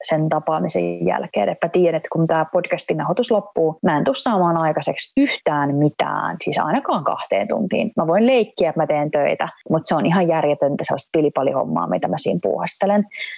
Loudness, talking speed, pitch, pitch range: -19 LUFS, 185 wpm, 160 Hz, 150-185 Hz